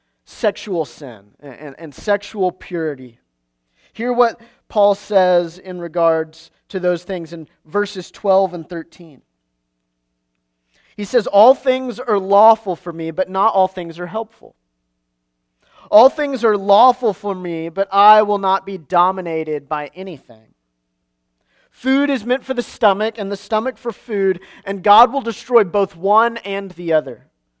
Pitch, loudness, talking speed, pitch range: 185 Hz, -17 LUFS, 150 wpm, 150-210 Hz